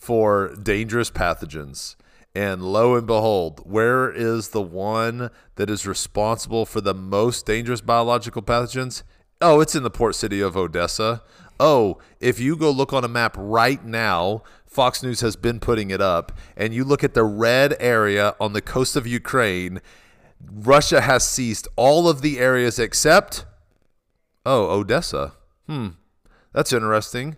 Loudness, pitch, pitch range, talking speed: -20 LUFS, 115 Hz, 100-125 Hz, 155 wpm